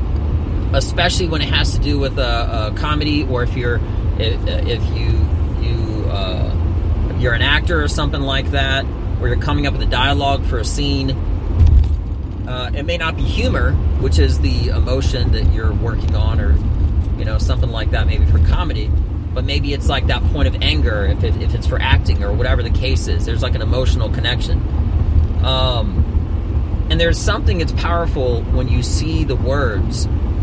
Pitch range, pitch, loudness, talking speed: 80-95 Hz, 85 Hz, -17 LUFS, 185 wpm